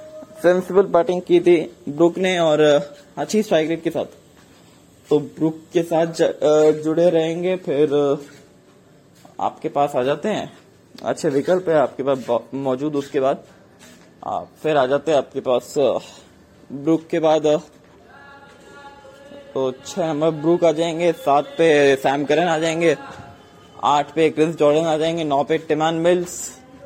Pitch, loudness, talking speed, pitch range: 160 Hz, -19 LUFS, 135 wpm, 145-170 Hz